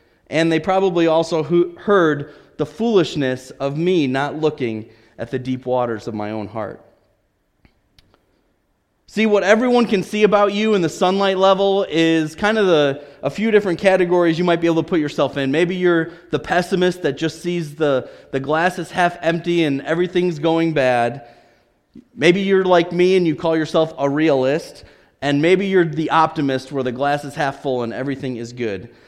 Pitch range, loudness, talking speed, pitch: 140-180 Hz, -18 LUFS, 180 wpm, 160 Hz